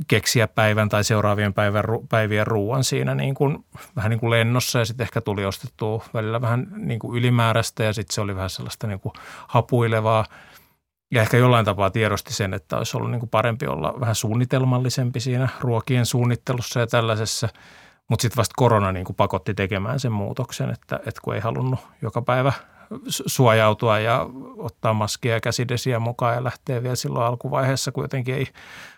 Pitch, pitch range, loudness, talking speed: 115 Hz, 110-125 Hz, -22 LUFS, 170 wpm